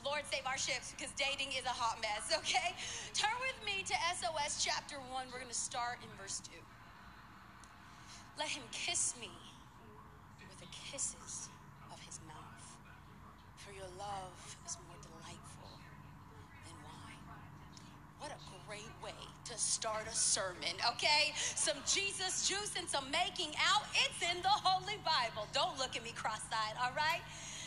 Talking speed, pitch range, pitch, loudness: 150 wpm, 245-355 Hz, 295 Hz, -37 LUFS